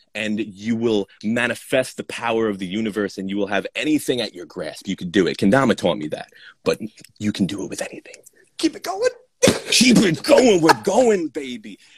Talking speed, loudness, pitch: 205 wpm, -20 LUFS, 120 Hz